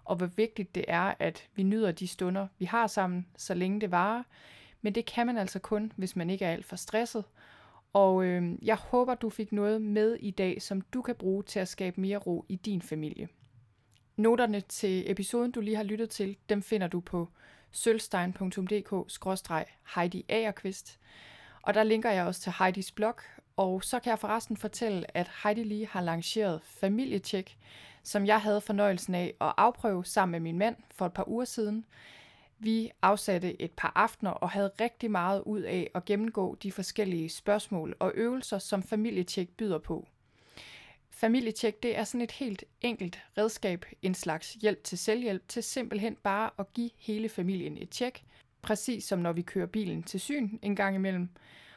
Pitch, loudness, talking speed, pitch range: 200 Hz, -32 LUFS, 180 wpm, 185-220 Hz